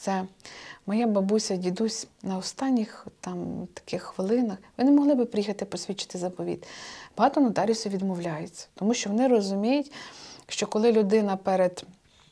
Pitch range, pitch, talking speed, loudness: 190-235 Hz, 210 Hz, 130 wpm, -27 LUFS